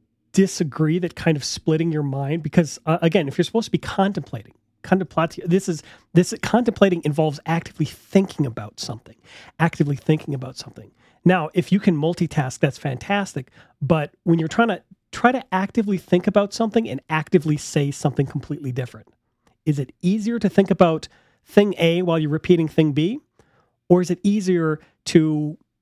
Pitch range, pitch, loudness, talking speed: 150-185 Hz, 165 Hz, -21 LUFS, 165 wpm